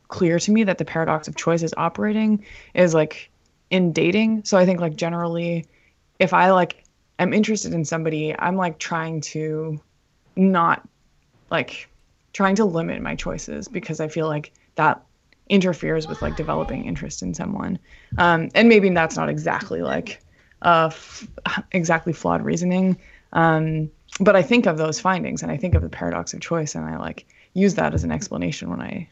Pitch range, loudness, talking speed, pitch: 160-190 Hz, -21 LUFS, 180 wpm, 170 Hz